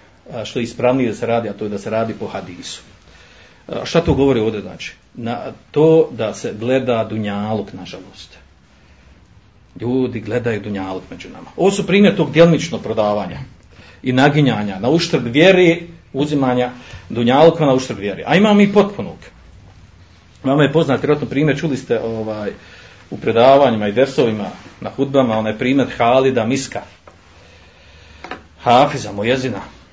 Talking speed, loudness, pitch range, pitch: 140 wpm, -16 LUFS, 100-140 Hz, 115 Hz